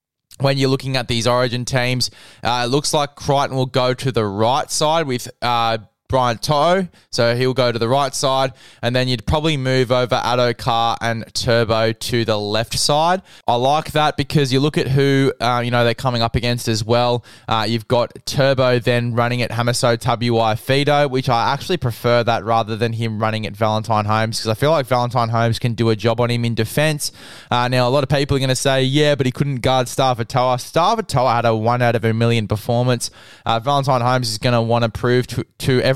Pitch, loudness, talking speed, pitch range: 125 Hz, -18 LUFS, 220 wpm, 115-135 Hz